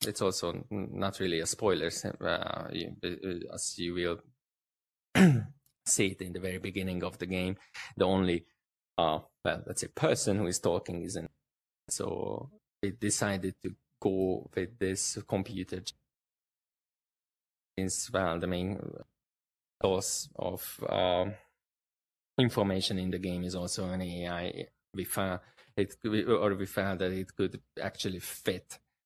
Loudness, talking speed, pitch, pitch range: -33 LUFS, 130 wpm, 95 Hz, 90-95 Hz